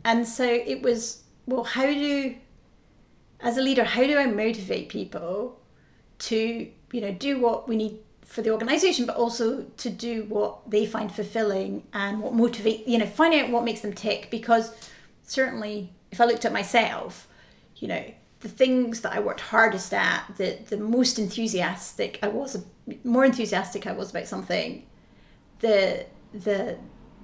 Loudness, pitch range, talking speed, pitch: -26 LUFS, 210-245 Hz, 165 wpm, 230 Hz